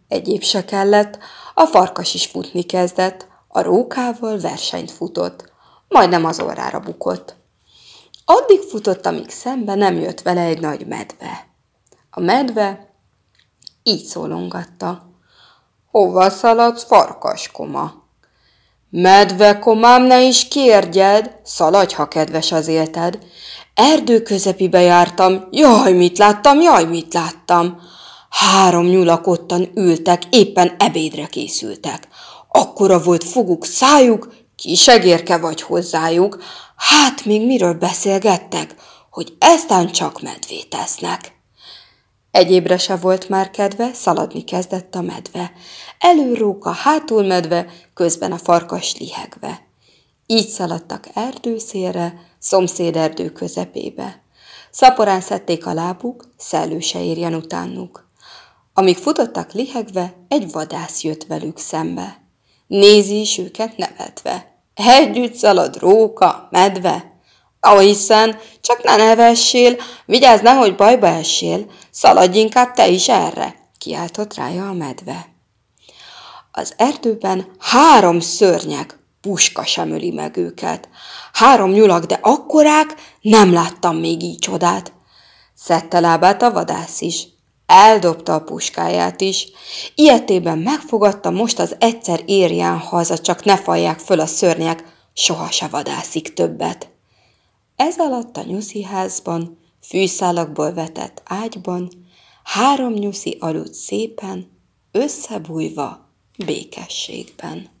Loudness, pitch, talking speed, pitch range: -14 LUFS, 190 Hz, 110 wpm, 175-225 Hz